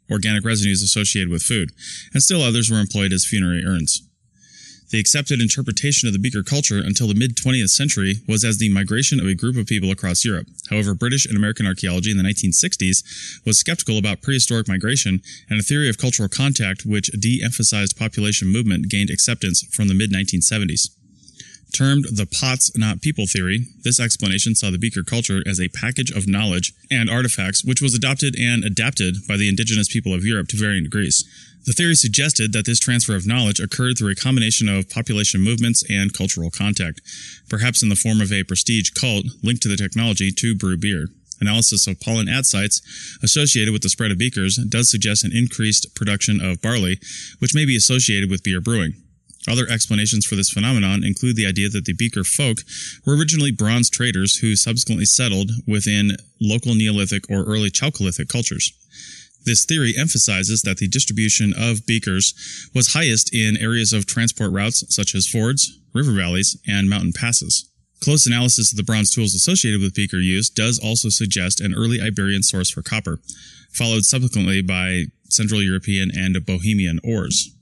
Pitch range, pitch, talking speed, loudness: 100-120 Hz, 110 Hz, 180 wpm, -18 LUFS